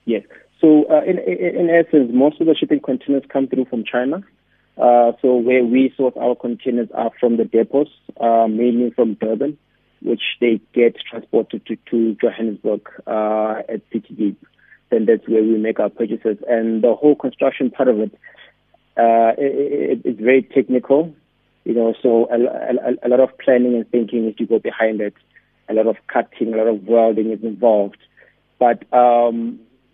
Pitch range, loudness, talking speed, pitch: 115-130 Hz, -17 LUFS, 180 wpm, 120 Hz